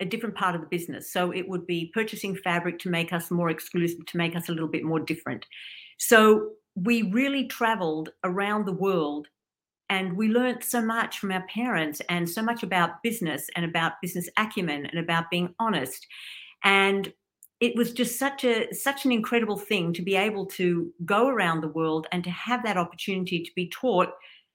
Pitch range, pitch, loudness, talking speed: 170-220 Hz, 185 Hz, -26 LUFS, 195 wpm